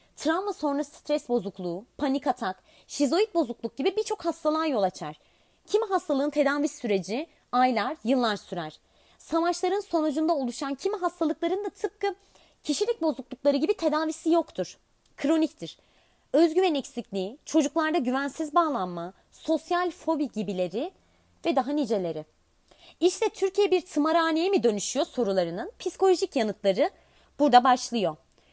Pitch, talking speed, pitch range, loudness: 295 Hz, 115 wpm, 240-340 Hz, -27 LUFS